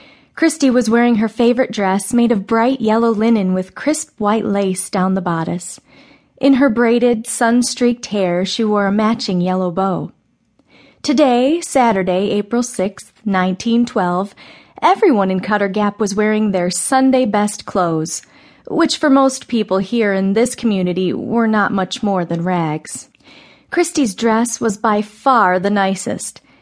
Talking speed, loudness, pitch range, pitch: 145 wpm, -16 LUFS, 190-240 Hz, 215 Hz